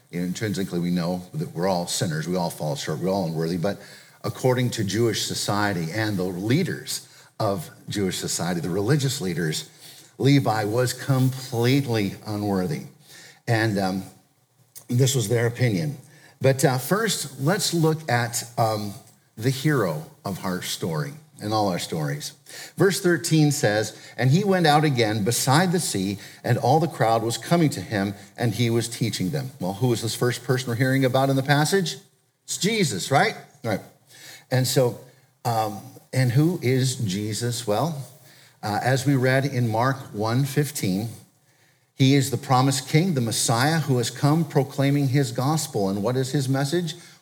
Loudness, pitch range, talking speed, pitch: -23 LUFS, 110-150 Hz, 165 wpm, 130 Hz